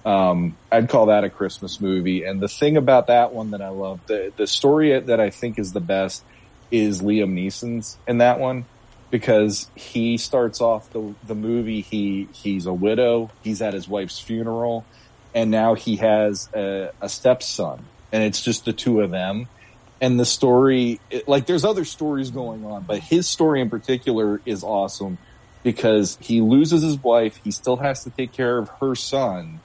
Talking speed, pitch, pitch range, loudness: 185 wpm, 115 Hz, 105-125 Hz, -21 LUFS